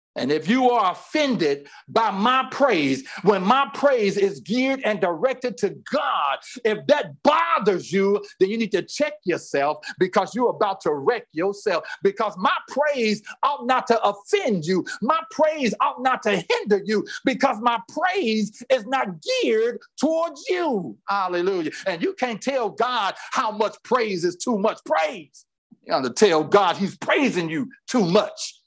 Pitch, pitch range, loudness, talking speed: 240 Hz, 200-285 Hz, -22 LUFS, 165 wpm